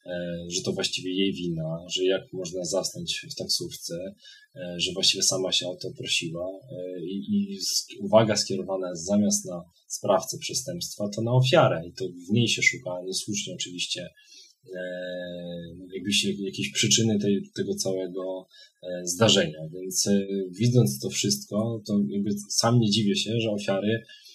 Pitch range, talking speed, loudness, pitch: 90-115 Hz, 140 wpm, -26 LUFS, 100 Hz